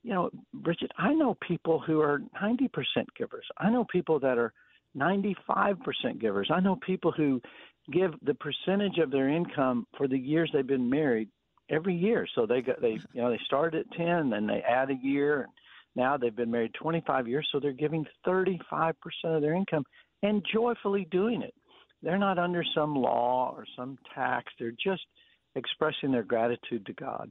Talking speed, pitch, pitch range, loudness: 190 wpm, 160 Hz, 135-190 Hz, -30 LUFS